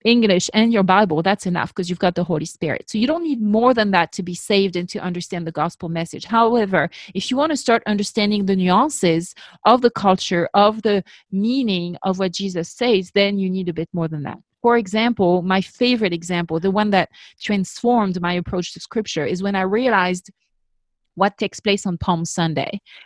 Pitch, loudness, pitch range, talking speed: 190 Hz, -19 LUFS, 175-215 Hz, 205 wpm